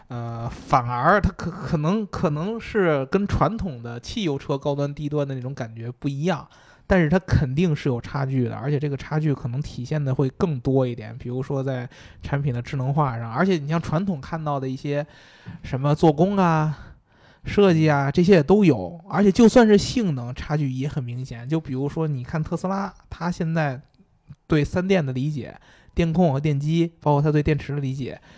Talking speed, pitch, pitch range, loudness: 285 characters per minute, 145 Hz, 130-170 Hz, -23 LUFS